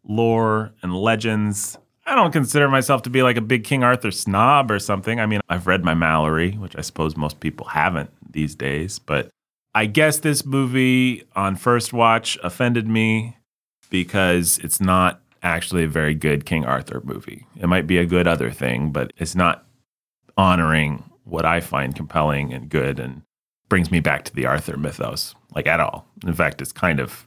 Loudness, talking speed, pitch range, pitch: -20 LUFS, 185 wpm, 80-115 Hz, 95 Hz